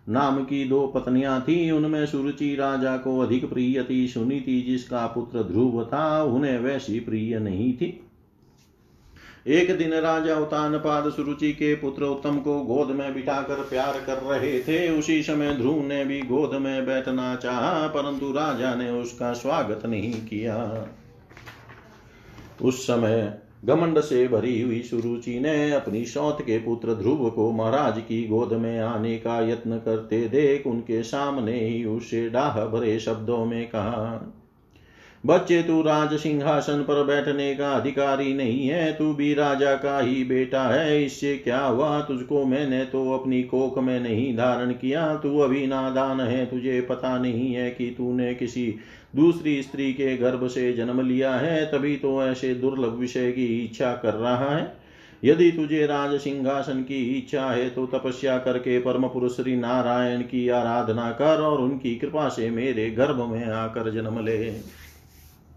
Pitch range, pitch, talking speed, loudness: 120-140 Hz, 130 Hz, 155 wpm, -24 LUFS